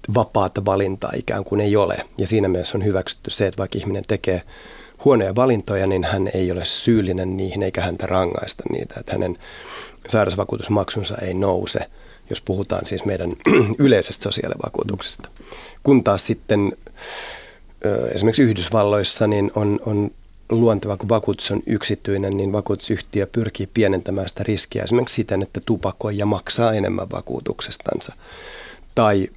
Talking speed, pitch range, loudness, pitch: 135 wpm, 95-110 Hz, -20 LUFS, 100 Hz